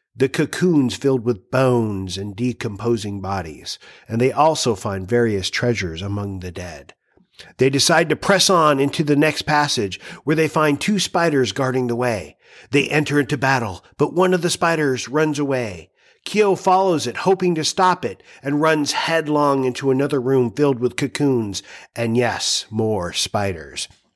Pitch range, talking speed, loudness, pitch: 115-155 Hz, 160 wpm, -19 LUFS, 130 Hz